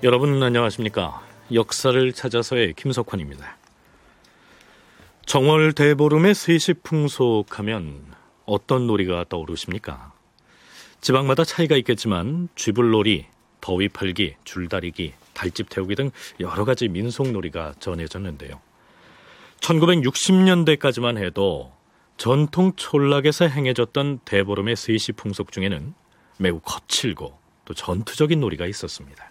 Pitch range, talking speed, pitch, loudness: 100-140 Hz, 275 characters per minute, 120 Hz, -21 LUFS